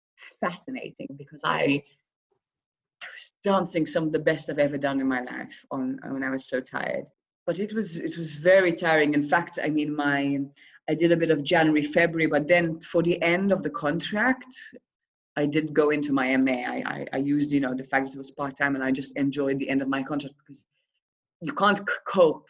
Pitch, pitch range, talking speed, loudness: 150 Hz, 140-170 Hz, 220 wpm, -25 LUFS